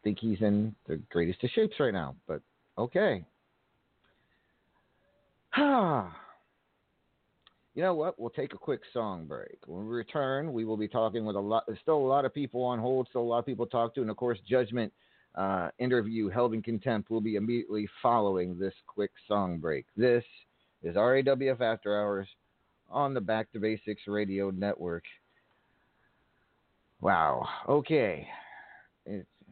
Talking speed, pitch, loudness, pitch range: 165 wpm, 115 Hz, -31 LUFS, 105-125 Hz